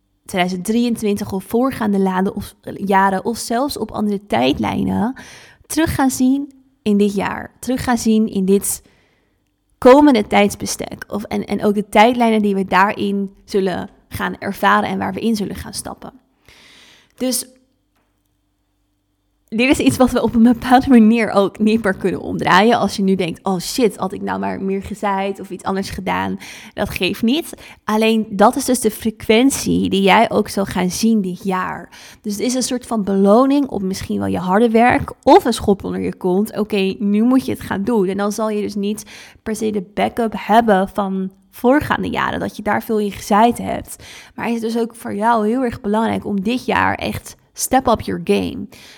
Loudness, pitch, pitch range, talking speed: -17 LUFS, 210 Hz, 195-235 Hz, 190 wpm